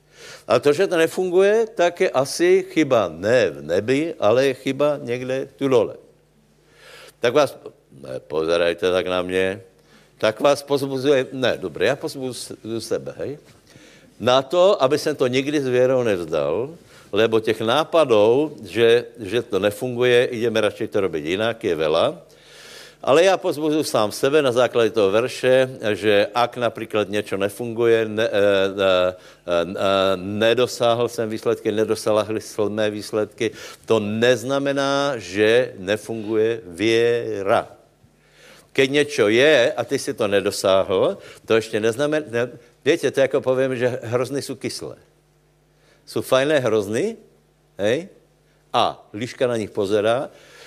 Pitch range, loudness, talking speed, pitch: 110-140 Hz, -20 LUFS, 140 wpm, 120 Hz